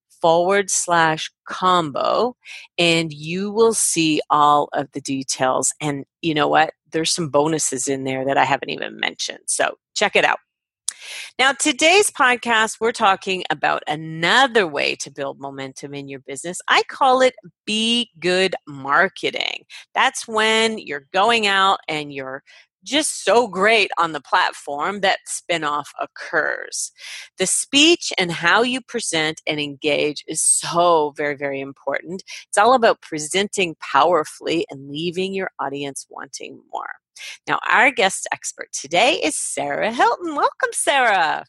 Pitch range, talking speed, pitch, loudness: 145-215 Hz, 145 wpm, 170 Hz, -19 LUFS